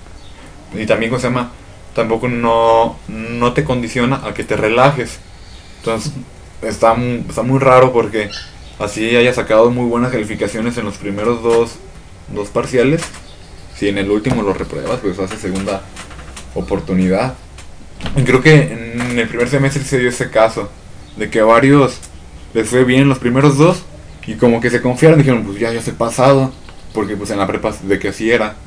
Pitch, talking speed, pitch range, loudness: 115 Hz, 175 wpm, 100-125 Hz, -14 LUFS